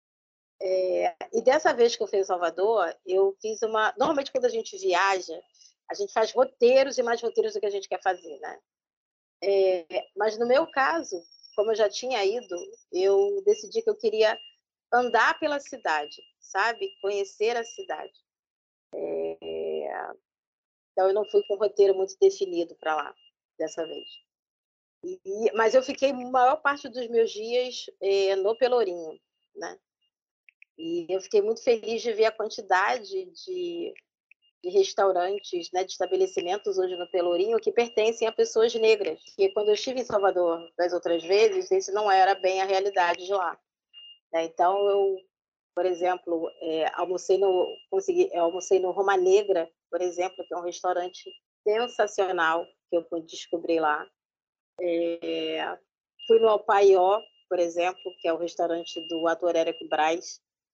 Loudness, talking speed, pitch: -26 LUFS, 160 wpm, 205 Hz